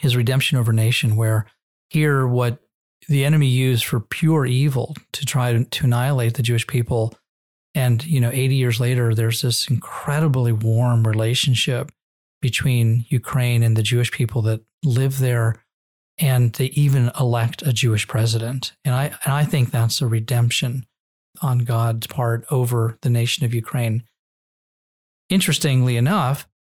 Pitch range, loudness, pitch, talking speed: 115-135 Hz, -20 LUFS, 125 Hz, 150 wpm